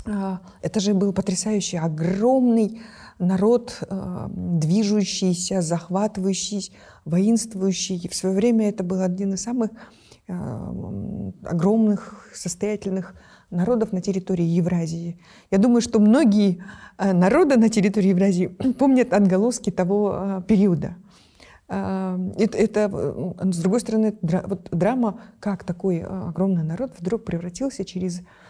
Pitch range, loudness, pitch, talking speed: 185-215 Hz, -22 LUFS, 195 Hz, 105 wpm